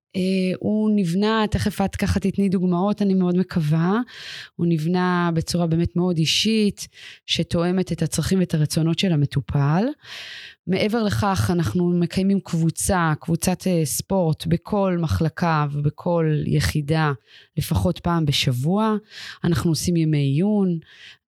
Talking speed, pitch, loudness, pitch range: 120 wpm, 175 Hz, -21 LUFS, 160-190 Hz